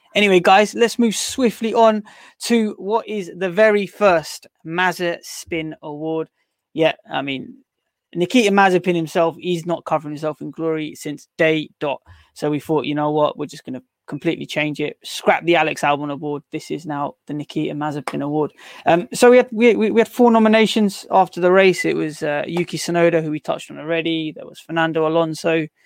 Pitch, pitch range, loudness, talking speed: 165 Hz, 150-200 Hz, -18 LUFS, 190 wpm